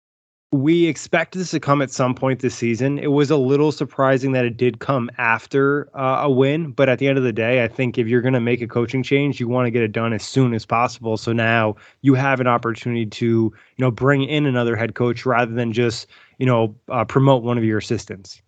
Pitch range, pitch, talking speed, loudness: 115-135 Hz, 125 Hz, 245 wpm, -19 LUFS